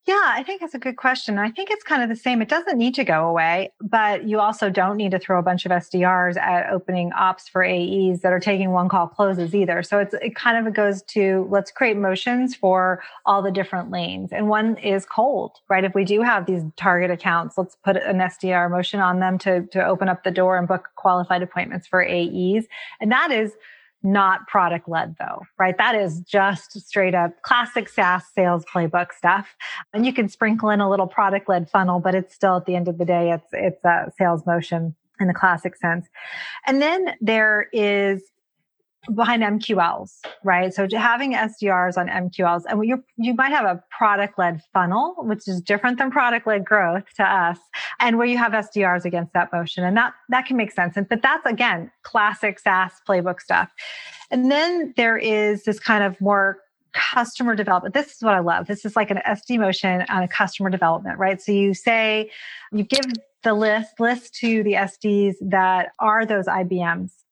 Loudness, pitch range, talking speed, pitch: -20 LUFS, 180-220 Hz, 200 wpm, 195 Hz